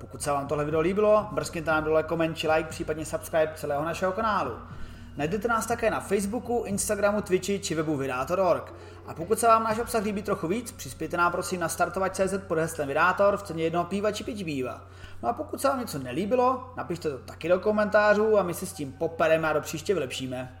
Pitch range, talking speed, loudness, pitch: 155-210 Hz, 210 wpm, -27 LUFS, 170 Hz